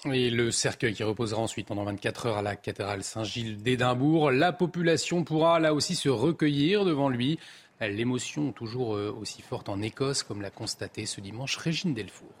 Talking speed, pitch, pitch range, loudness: 175 wpm, 125 Hz, 110-150 Hz, -28 LUFS